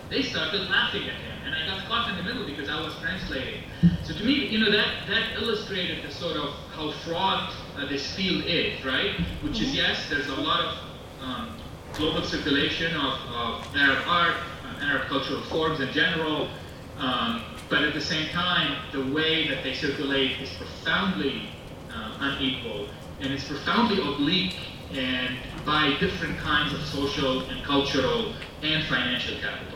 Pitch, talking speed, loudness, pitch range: 150 Hz, 170 wpm, -26 LUFS, 135-170 Hz